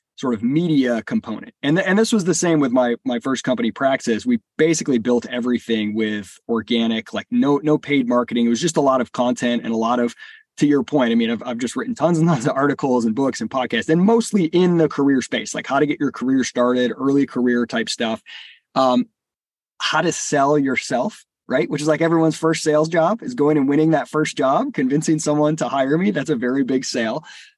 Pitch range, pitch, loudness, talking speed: 125-160 Hz, 145 Hz, -19 LUFS, 225 wpm